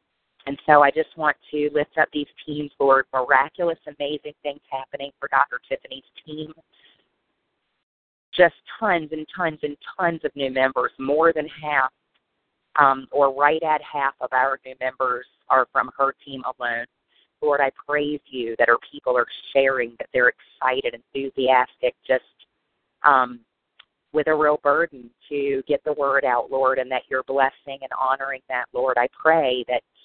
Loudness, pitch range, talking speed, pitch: -22 LUFS, 130-150 Hz, 160 wpm, 140 Hz